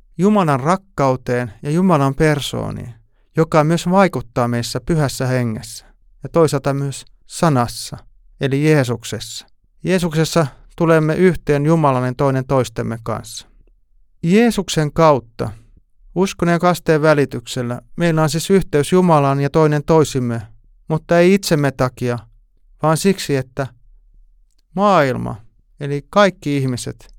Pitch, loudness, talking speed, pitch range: 140 Hz, -17 LUFS, 110 wpm, 120-160 Hz